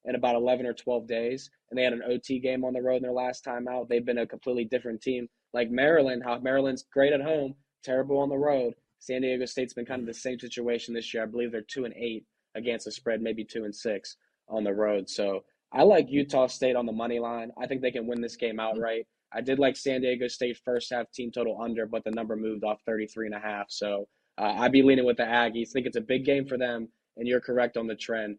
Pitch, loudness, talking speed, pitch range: 120 Hz, -29 LUFS, 260 wpm, 115-130 Hz